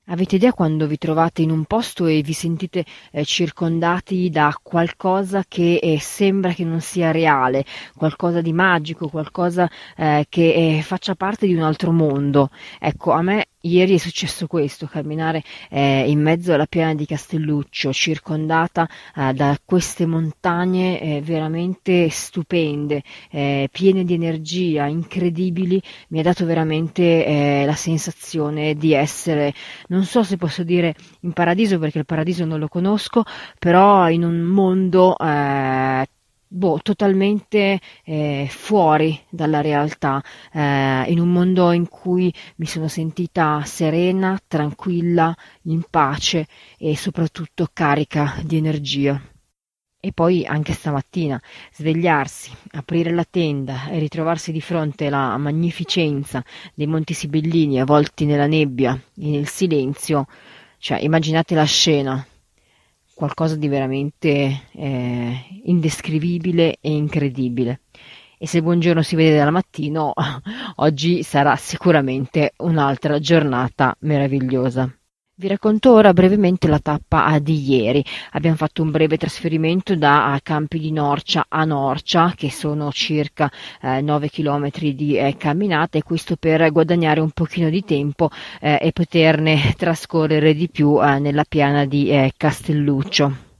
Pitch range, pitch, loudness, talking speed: 145-175 Hz, 160 Hz, -19 LUFS, 135 wpm